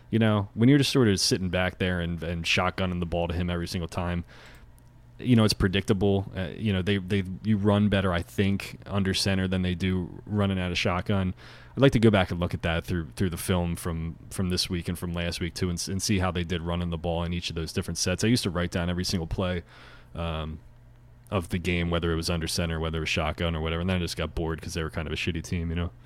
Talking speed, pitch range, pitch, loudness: 275 wpm, 85-100 Hz, 90 Hz, -27 LUFS